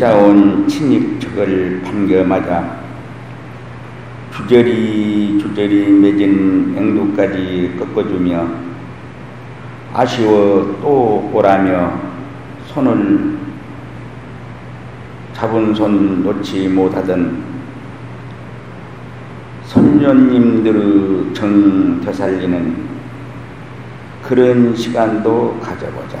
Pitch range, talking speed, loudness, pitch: 95-120 Hz, 145 characters per minute, -14 LUFS, 105 Hz